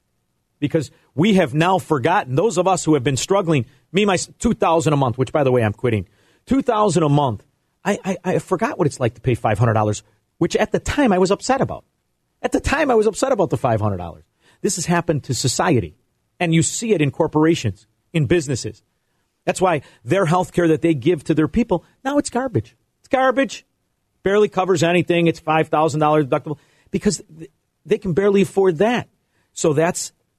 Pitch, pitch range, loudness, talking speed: 165 Hz, 135-190 Hz, -19 LUFS, 210 wpm